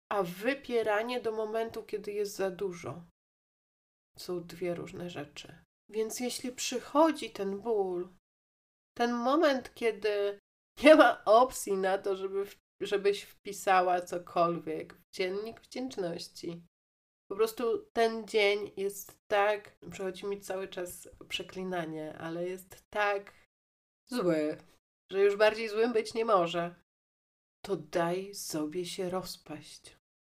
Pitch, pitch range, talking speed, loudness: 195 Hz, 175-225 Hz, 120 wpm, -31 LUFS